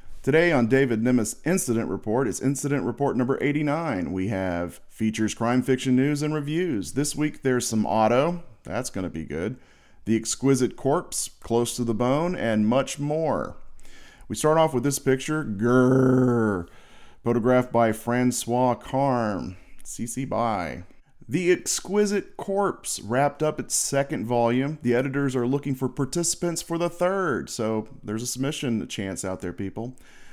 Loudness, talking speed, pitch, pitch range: -25 LUFS, 150 wpm, 125 Hz, 115-145 Hz